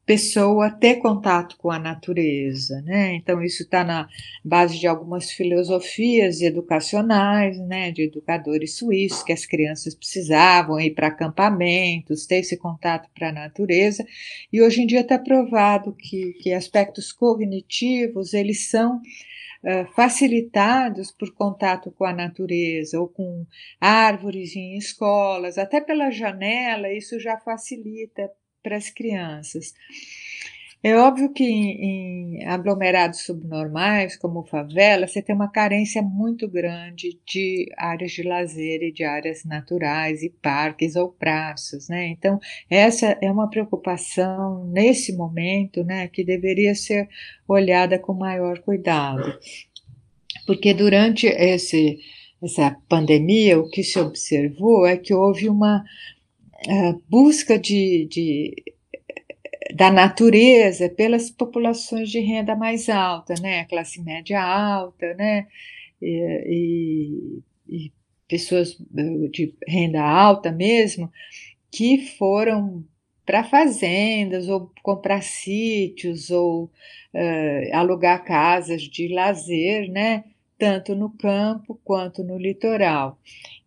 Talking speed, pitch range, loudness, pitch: 120 wpm, 170-210 Hz, -20 LUFS, 190 Hz